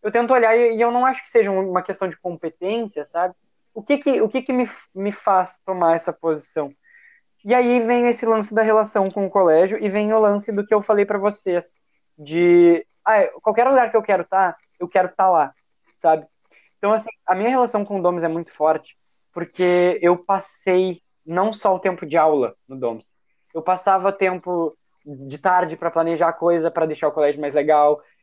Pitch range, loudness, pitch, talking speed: 170-220 Hz, -19 LUFS, 190 Hz, 210 wpm